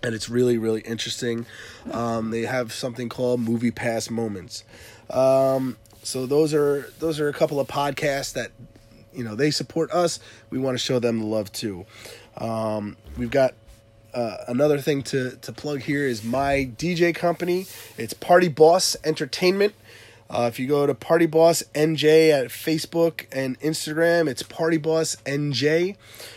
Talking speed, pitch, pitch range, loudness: 160 wpm, 135 Hz, 115-155 Hz, -23 LUFS